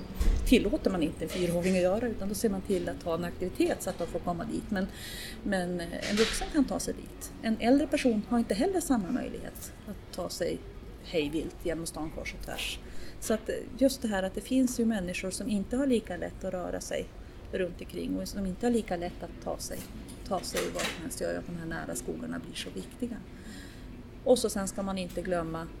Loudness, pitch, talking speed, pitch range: -32 LUFS, 200 Hz, 225 wpm, 180-240 Hz